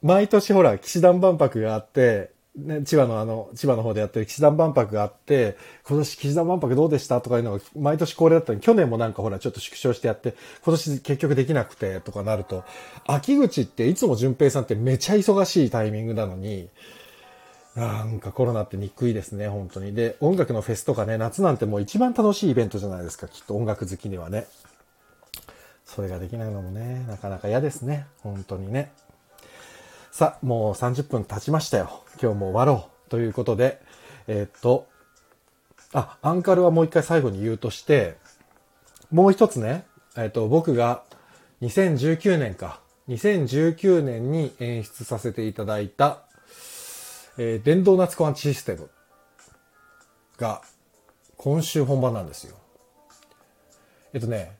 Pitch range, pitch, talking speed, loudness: 110-155 Hz, 125 Hz, 335 characters per minute, -23 LUFS